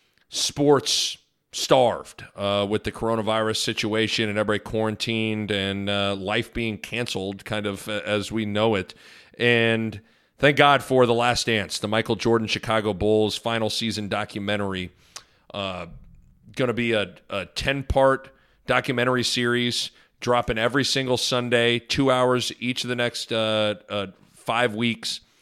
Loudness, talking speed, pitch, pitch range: -23 LUFS, 140 wpm, 115 Hz, 105-120 Hz